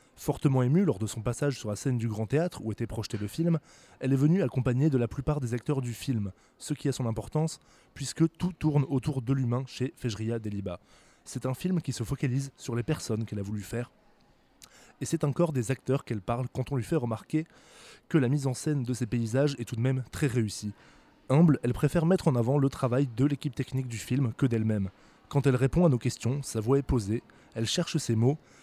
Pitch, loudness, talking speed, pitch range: 130 Hz, -29 LUFS, 230 wpm, 120-145 Hz